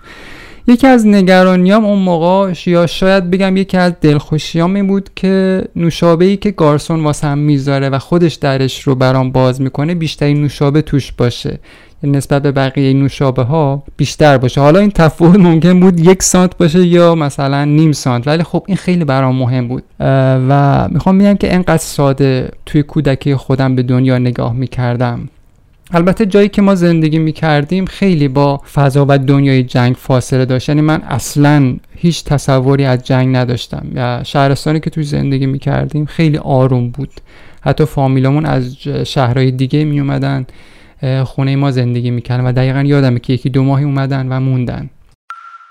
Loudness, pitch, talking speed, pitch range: -12 LUFS, 145 Hz, 165 wpm, 130-170 Hz